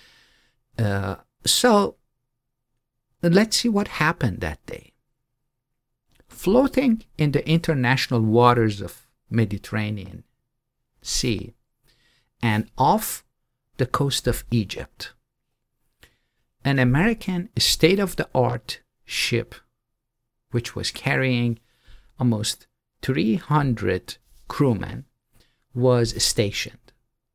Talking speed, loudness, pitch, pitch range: 75 wpm, -22 LUFS, 125 Hz, 115-135 Hz